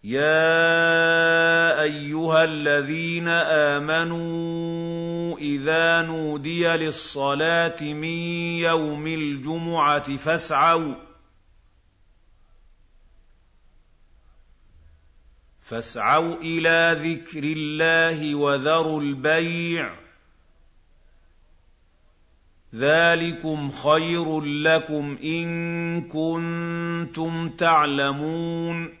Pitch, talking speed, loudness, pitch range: 155 Hz, 50 wpm, -22 LUFS, 105-165 Hz